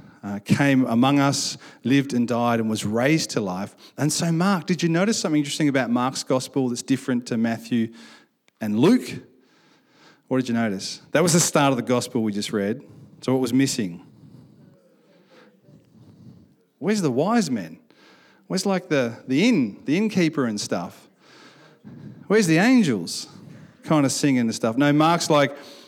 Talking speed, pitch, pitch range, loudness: 165 wpm, 140 Hz, 120-170 Hz, -22 LUFS